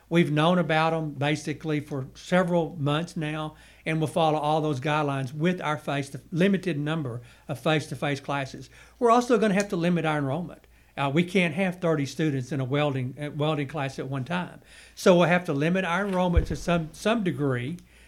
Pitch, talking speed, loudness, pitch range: 155 Hz, 190 wpm, -26 LUFS, 145-175 Hz